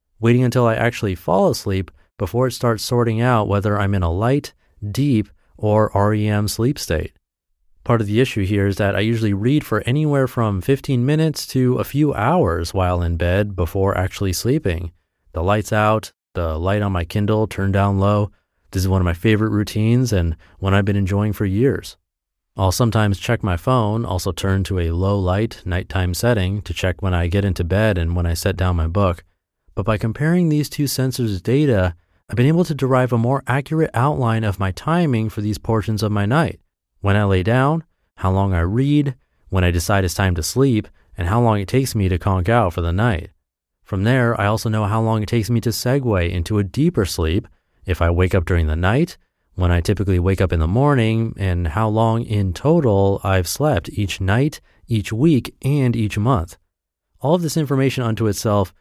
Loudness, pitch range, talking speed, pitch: -19 LUFS, 90-120 Hz, 205 wpm, 105 Hz